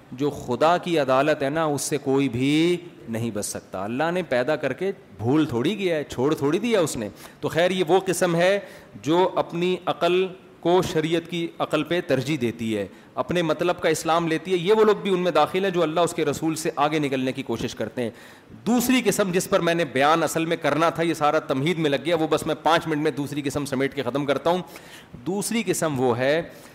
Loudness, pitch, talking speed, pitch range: -23 LUFS, 160 Hz, 235 wpm, 140-175 Hz